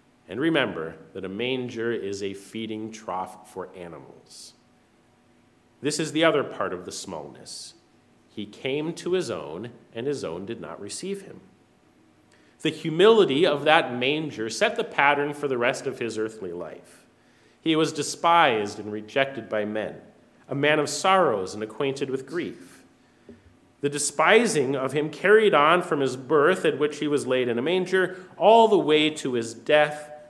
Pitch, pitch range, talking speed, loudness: 140 Hz, 110-155 Hz, 165 wpm, -24 LUFS